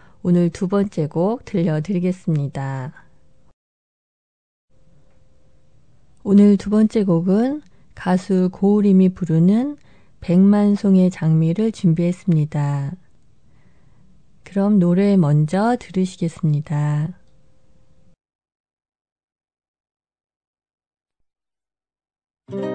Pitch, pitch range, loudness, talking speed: 185 Hz, 160-200 Hz, -18 LUFS, 150 characters per minute